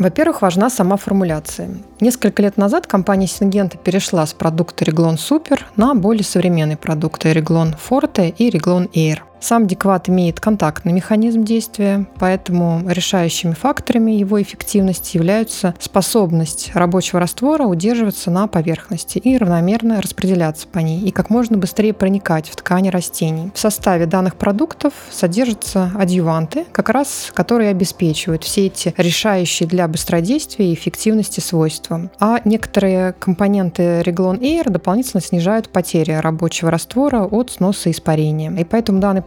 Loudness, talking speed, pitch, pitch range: -16 LUFS, 135 wpm, 190 Hz, 170-215 Hz